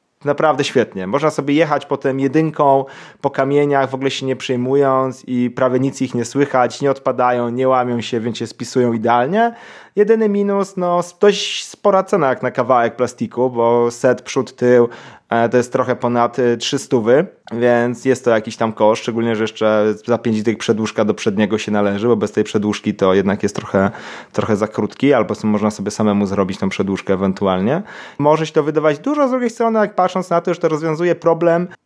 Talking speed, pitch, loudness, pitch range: 190 wpm, 125 Hz, -17 LUFS, 115-150 Hz